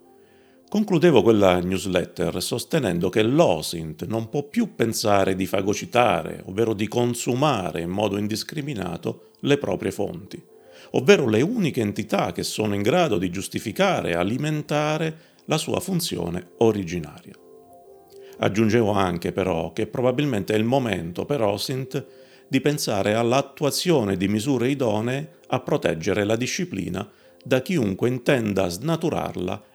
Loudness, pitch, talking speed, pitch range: -23 LUFS, 115 Hz, 125 wpm, 95-145 Hz